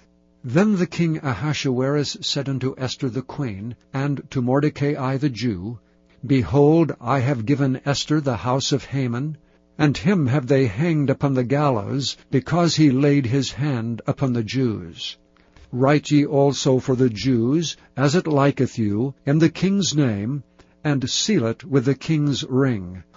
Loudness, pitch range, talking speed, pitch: -21 LUFS, 125-145 Hz, 155 wpm, 135 Hz